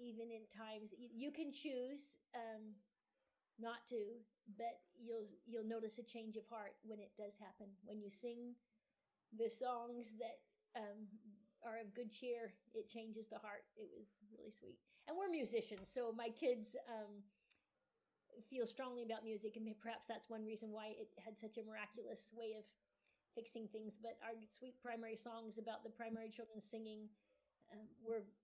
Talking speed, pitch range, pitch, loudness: 165 wpm, 215-235 Hz, 225 Hz, -51 LUFS